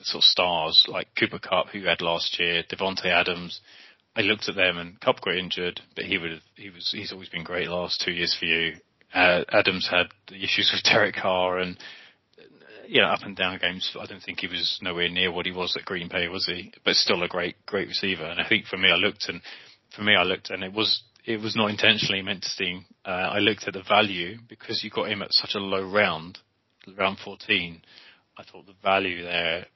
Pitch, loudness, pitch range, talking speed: 90 Hz, -24 LUFS, 85-100 Hz, 230 wpm